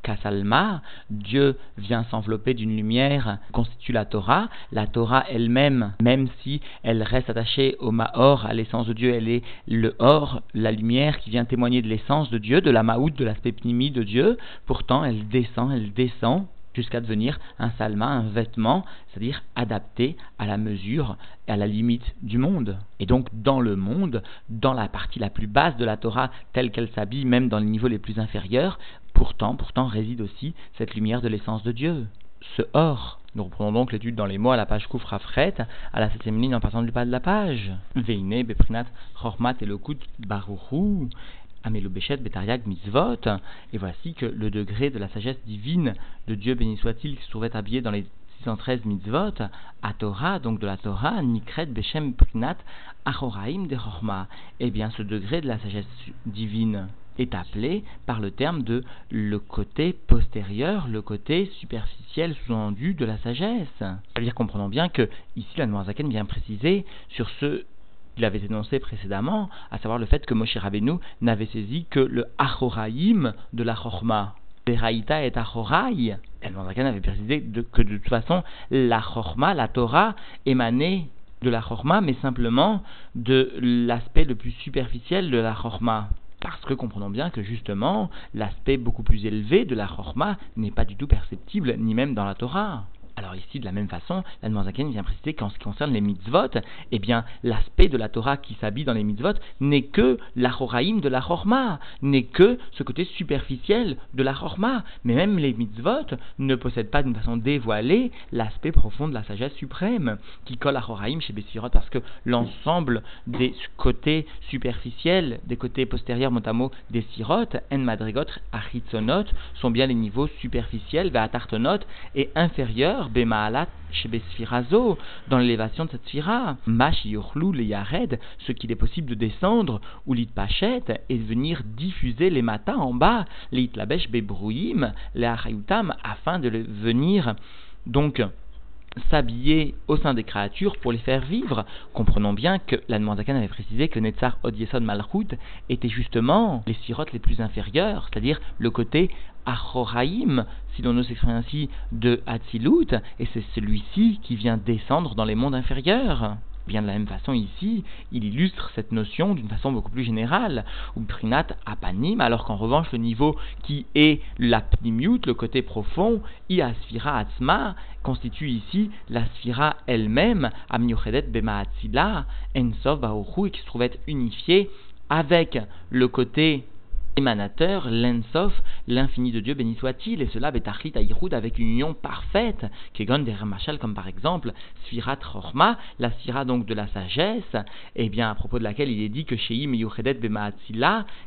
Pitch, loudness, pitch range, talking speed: 120 Hz, -25 LUFS, 110-135 Hz, 165 wpm